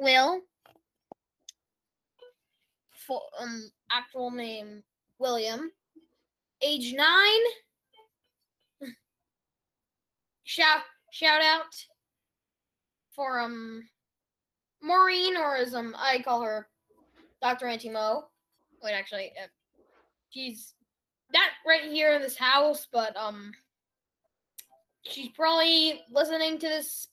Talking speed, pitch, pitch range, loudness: 90 wpm, 270 Hz, 230-320 Hz, -26 LUFS